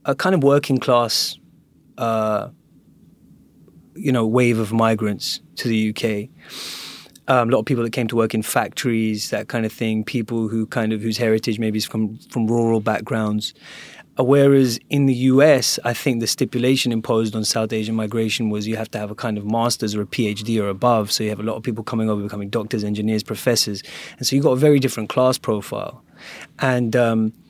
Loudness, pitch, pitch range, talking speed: -20 LUFS, 115 Hz, 110-125 Hz, 200 wpm